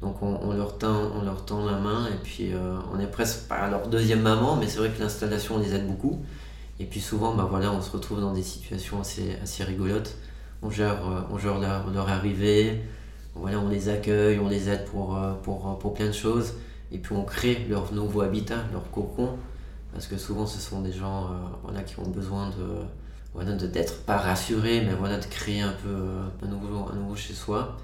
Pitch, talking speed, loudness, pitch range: 100 Hz, 215 wpm, -28 LUFS, 95-105 Hz